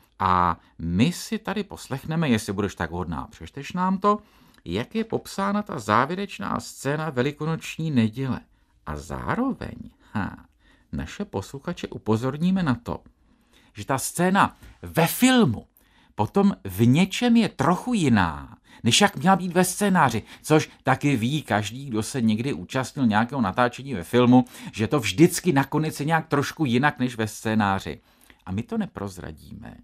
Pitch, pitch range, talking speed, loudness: 135 Hz, 110-175 Hz, 145 wpm, -24 LUFS